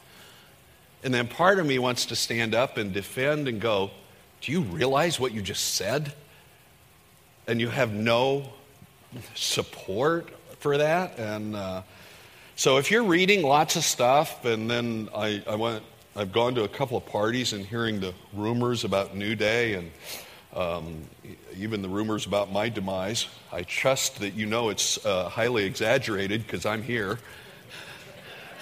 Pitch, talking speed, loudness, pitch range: 115 Hz, 155 wpm, -26 LUFS, 105-135 Hz